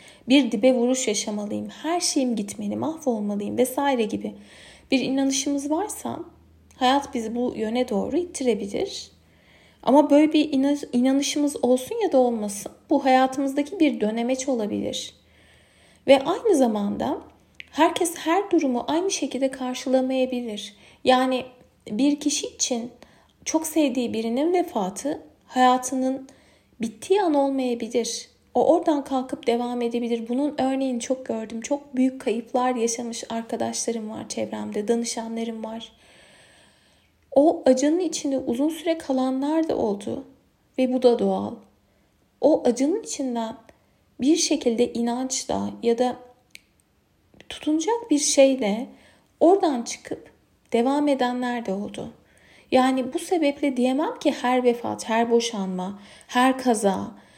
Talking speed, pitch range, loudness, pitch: 115 wpm, 235-290 Hz, -23 LUFS, 255 Hz